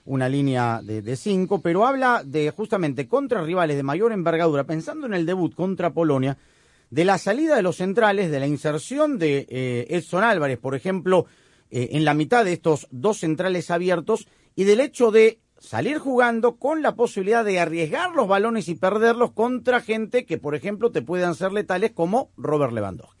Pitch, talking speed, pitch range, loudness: 180 Hz, 185 wpm, 150-225 Hz, -22 LUFS